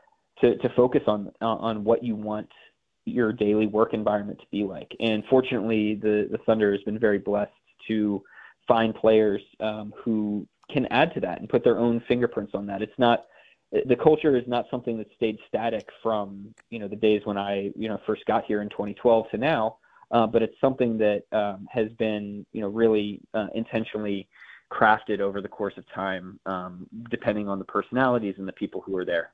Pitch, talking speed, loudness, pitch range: 110 Hz, 195 wpm, -26 LUFS, 105-115 Hz